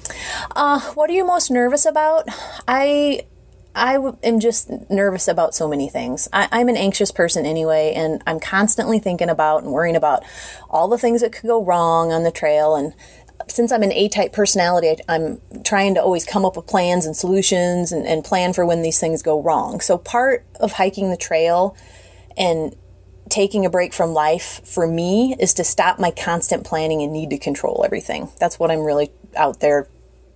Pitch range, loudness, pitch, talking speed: 160-220 Hz, -18 LUFS, 180 Hz, 195 wpm